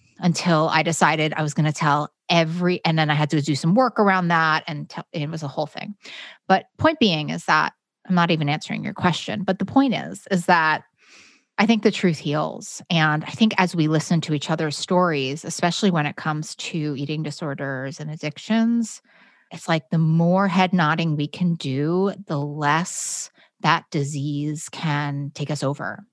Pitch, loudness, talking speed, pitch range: 165 Hz, -22 LUFS, 195 wpm, 150-185 Hz